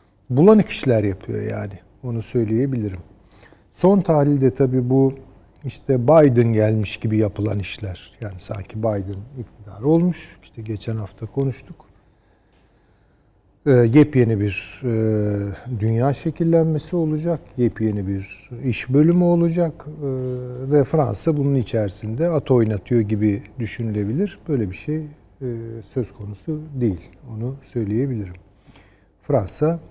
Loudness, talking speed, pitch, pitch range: -20 LUFS, 110 wpm, 115 Hz, 105-140 Hz